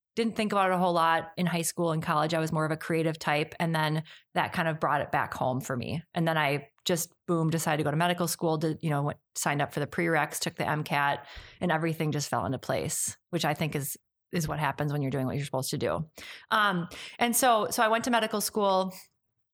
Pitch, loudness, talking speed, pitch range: 160 Hz, -29 LUFS, 255 wpm, 145-175 Hz